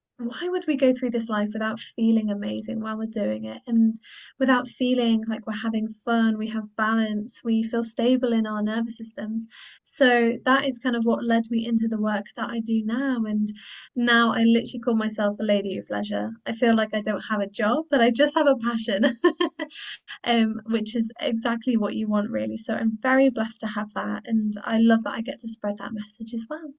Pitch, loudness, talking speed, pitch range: 225 Hz, -24 LUFS, 215 wpm, 215-245 Hz